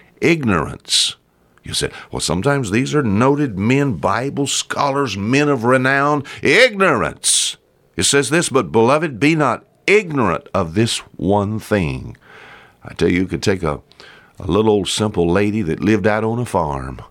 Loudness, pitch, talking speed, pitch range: -17 LUFS, 110 Hz, 160 wpm, 95-140 Hz